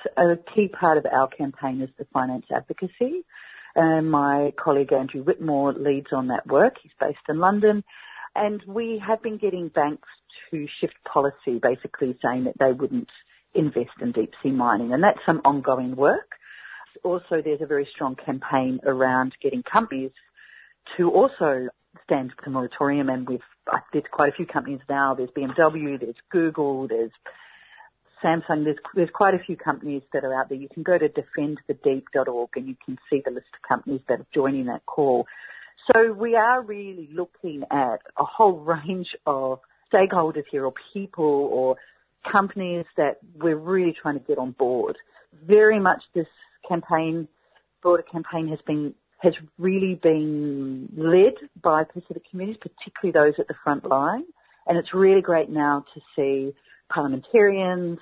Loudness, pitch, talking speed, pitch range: -23 LUFS, 160 Hz, 165 wpm, 140-190 Hz